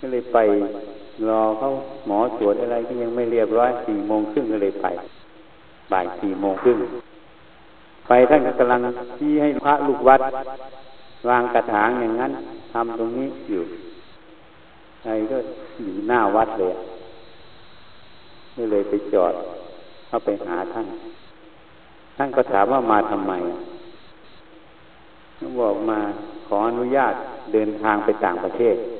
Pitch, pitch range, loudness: 120 Hz, 110-135 Hz, -21 LUFS